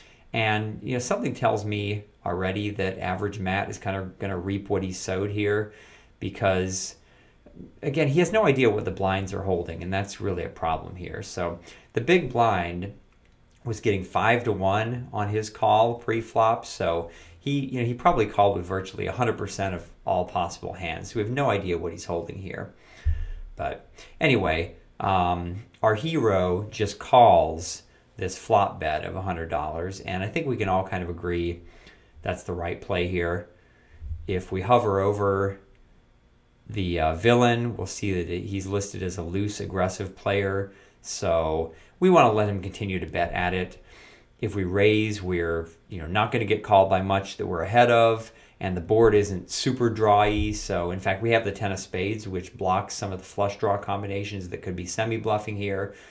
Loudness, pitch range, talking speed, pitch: -25 LUFS, 90-105 Hz, 185 wpm, 100 Hz